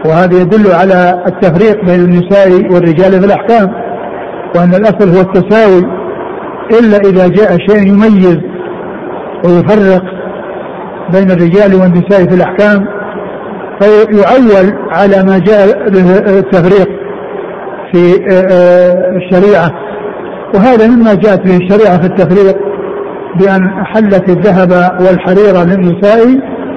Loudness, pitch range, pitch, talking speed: -6 LUFS, 185-205 Hz, 195 Hz, 100 wpm